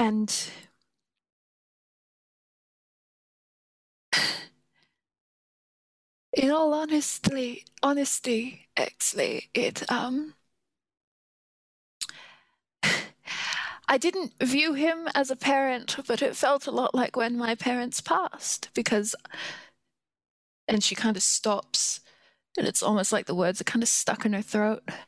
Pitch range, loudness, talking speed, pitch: 220-295 Hz, -27 LUFS, 105 wpm, 250 Hz